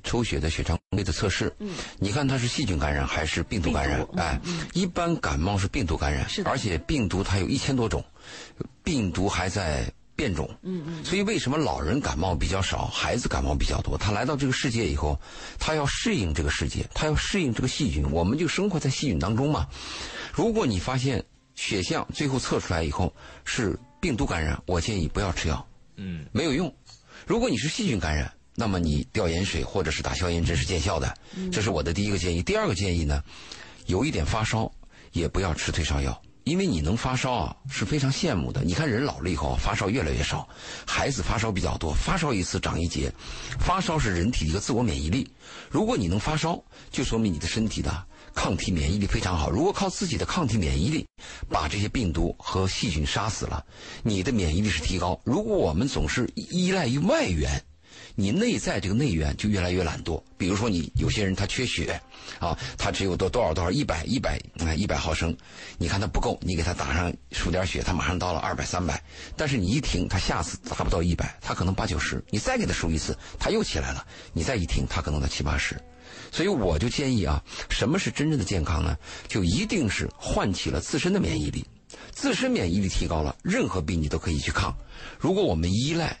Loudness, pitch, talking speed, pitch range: -27 LUFS, 90 Hz, 320 characters per minute, 80-110 Hz